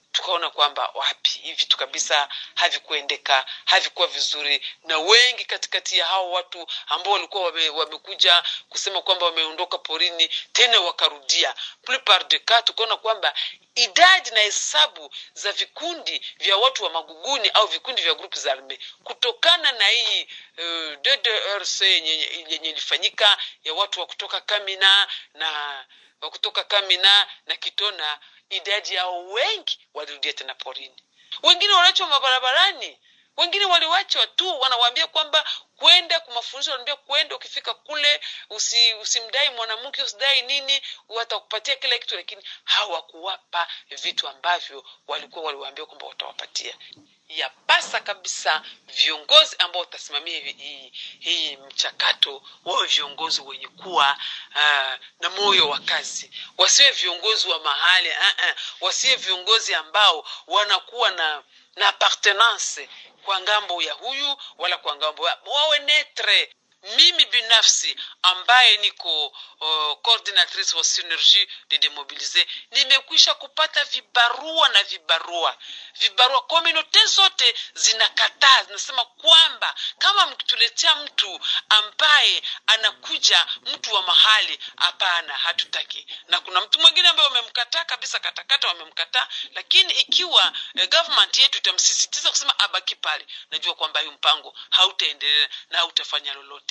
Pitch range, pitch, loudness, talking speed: 175-285 Hz, 215 Hz, -19 LUFS, 120 wpm